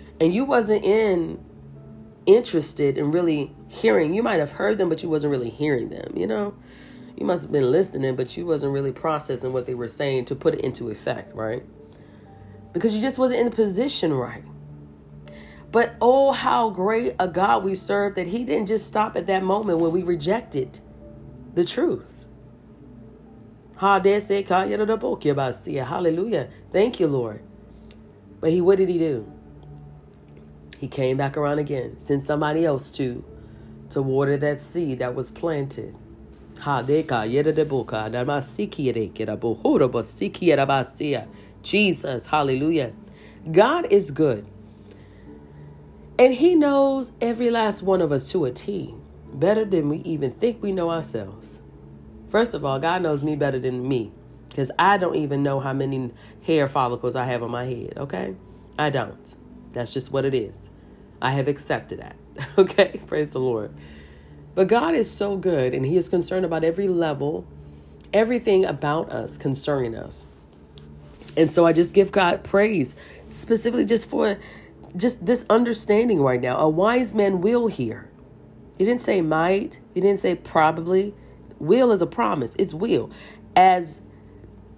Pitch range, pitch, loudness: 115-195 Hz, 145 Hz, -22 LUFS